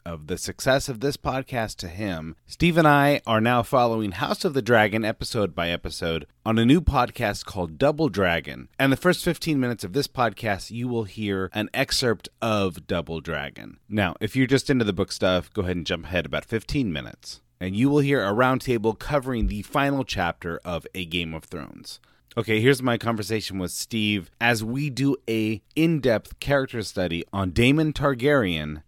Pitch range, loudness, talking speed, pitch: 90-135 Hz, -24 LUFS, 190 wpm, 110 Hz